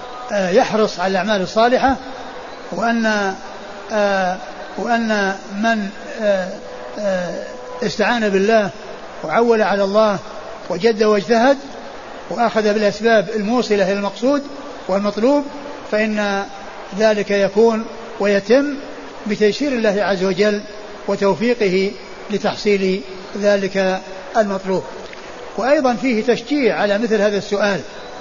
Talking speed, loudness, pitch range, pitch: 85 wpm, -18 LUFS, 200-230 Hz, 210 Hz